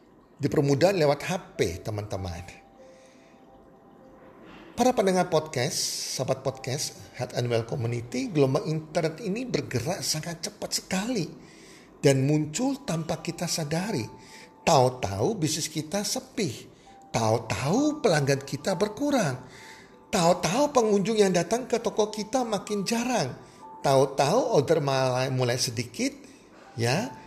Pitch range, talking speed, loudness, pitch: 130-205 Hz, 105 wpm, -27 LUFS, 160 Hz